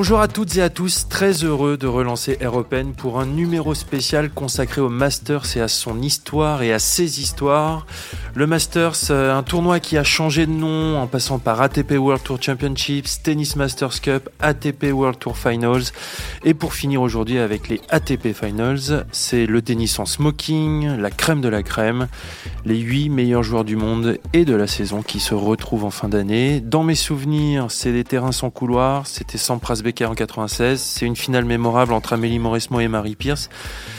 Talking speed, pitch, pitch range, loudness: 190 wpm, 130 Hz, 115-150 Hz, -19 LUFS